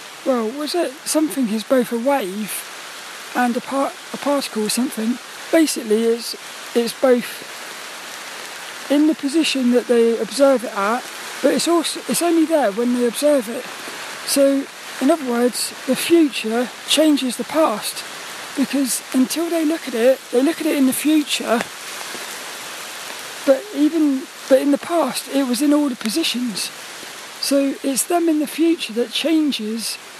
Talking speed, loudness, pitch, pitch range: 160 wpm, -19 LUFS, 270 Hz, 245-305 Hz